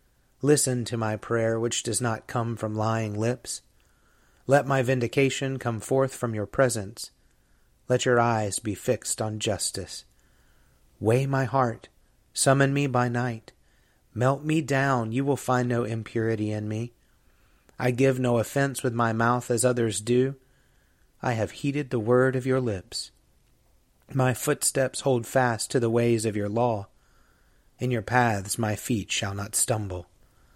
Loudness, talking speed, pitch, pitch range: -26 LUFS, 155 wpm, 120 Hz, 110-130 Hz